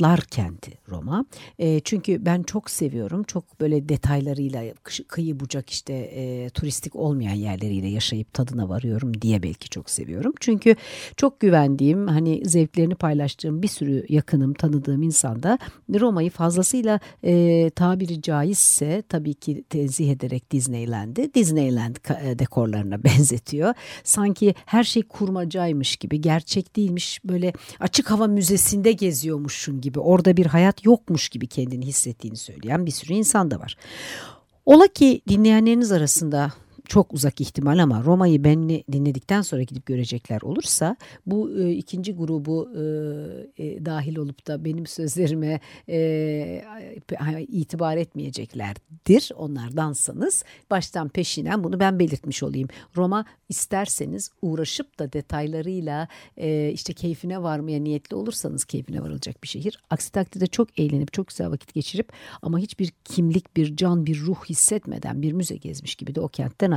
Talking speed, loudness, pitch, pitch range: 135 wpm, -22 LUFS, 160 Hz, 140-185 Hz